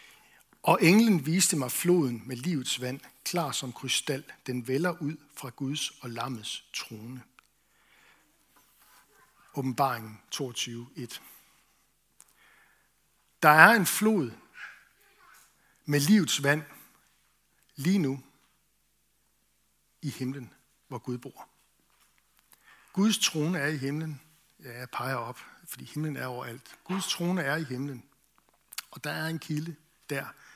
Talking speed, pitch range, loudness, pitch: 115 wpm, 125-160 Hz, -28 LUFS, 140 Hz